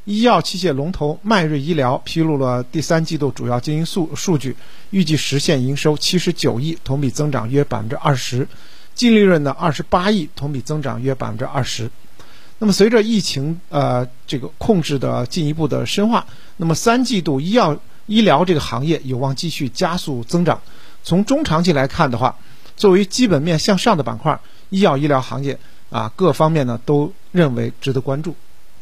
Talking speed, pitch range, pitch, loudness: 285 characters per minute, 135-180 Hz, 150 Hz, -18 LUFS